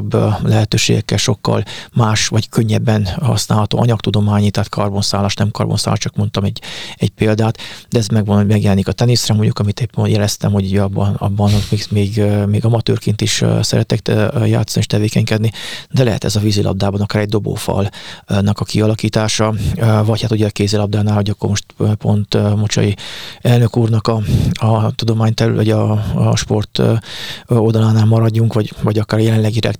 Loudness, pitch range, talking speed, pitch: -15 LUFS, 105-110 Hz, 145 wpm, 110 Hz